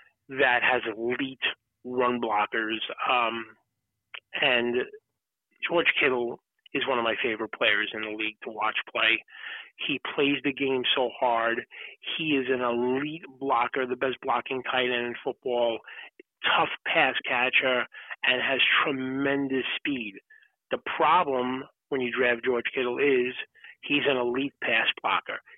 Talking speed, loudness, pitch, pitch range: 140 wpm, -26 LUFS, 130 Hz, 120-140 Hz